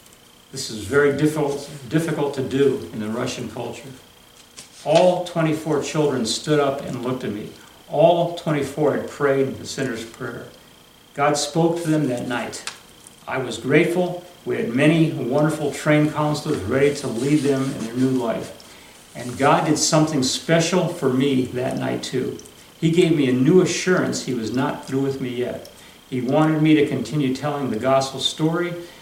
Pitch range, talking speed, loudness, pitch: 130-155 Hz, 170 wpm, -21 LUFS, 145 Hz